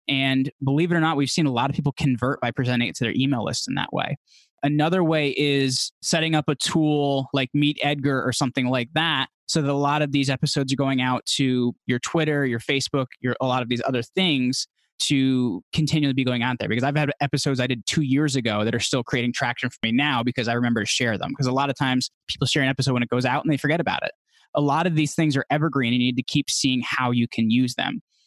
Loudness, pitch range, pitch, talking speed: -23 LUFS, 125-145 Hz, 135 Hz, 265 wpm